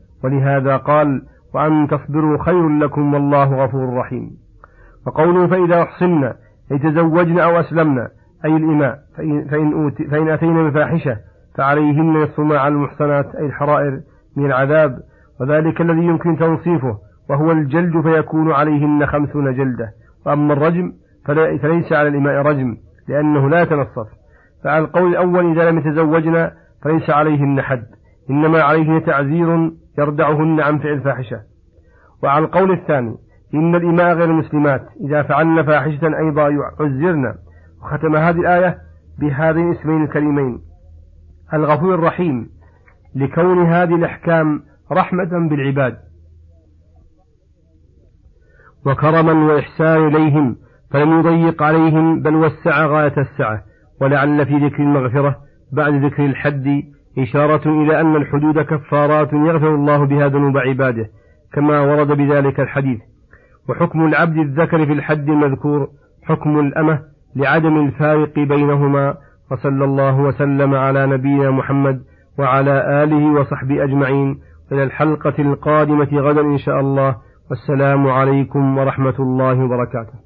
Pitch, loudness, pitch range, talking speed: 145 Hz, -15 LUFS, 135-155 Hz, 115 wpm